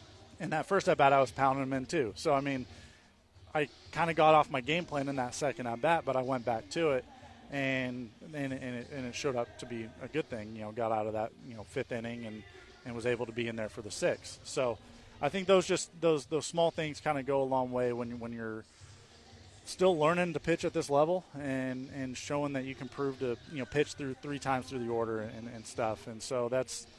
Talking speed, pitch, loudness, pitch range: 255 wpm, 130 Hz, -33 LUFS, 115-145 Hz